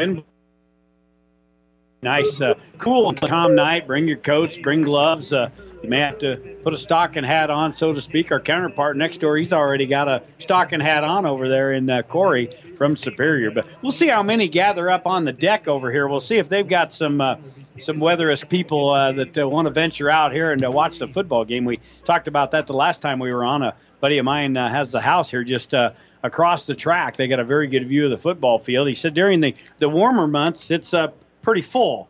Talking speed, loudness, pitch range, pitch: 230 wpm, -19 LUFS, 135-165 Hz, 150 Hz